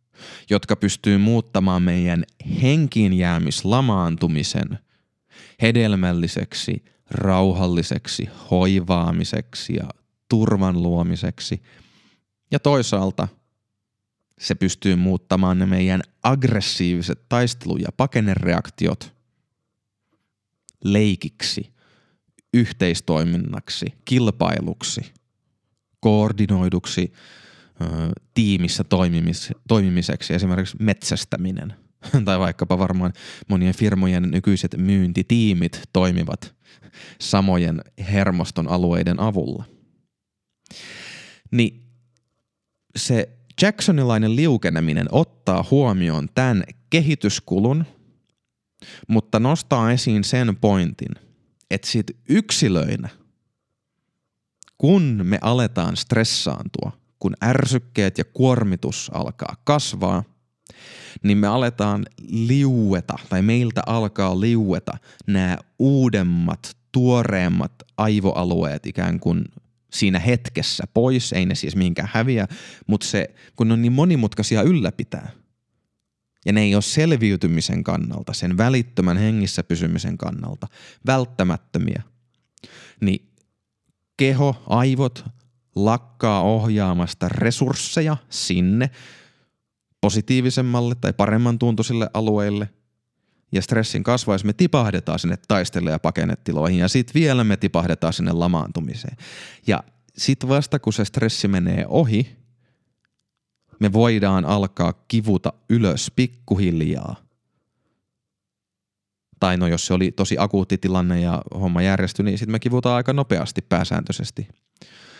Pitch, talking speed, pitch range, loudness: 105 Hz, 90 wpm, 90-120 Hz, -21 LUFS